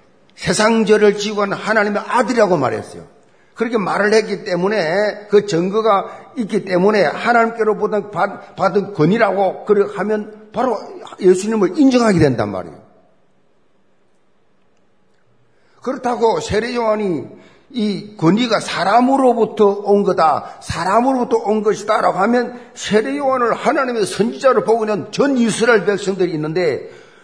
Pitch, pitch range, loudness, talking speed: 210 Hz, 195-230 Hz, -16 LUFS, 295 characters per minute